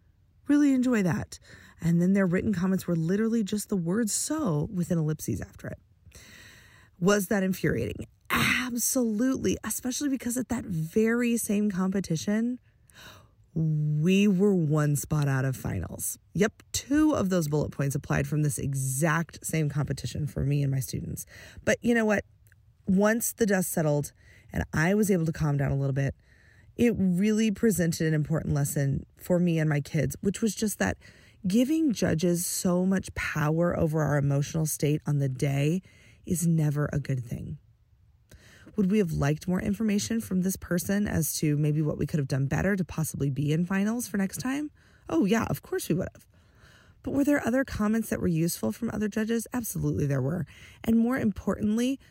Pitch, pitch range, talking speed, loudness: 170 Hz, 145-210 Hz, 175 wpm, -27 LUFS